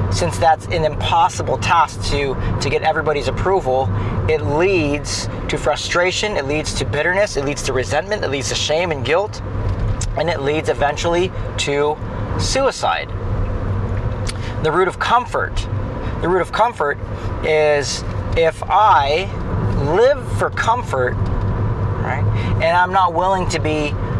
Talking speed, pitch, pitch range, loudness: 135 wpm, 110 Hz, 100-150 Hz, -18 LUFS